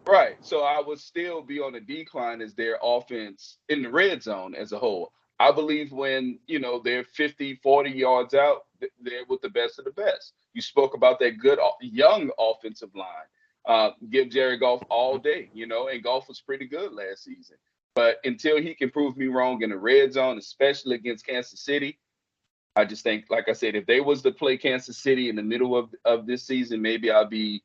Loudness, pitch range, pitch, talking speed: -25 LUFS, 120-205 Hz, 135 Hz, 215 wpm